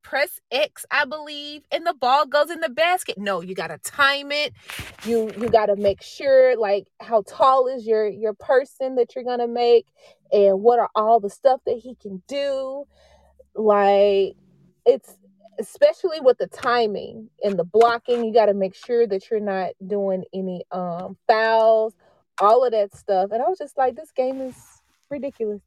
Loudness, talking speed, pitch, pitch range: -21 LUFS, 185 wpm, 235 Hz, 205-275 Hz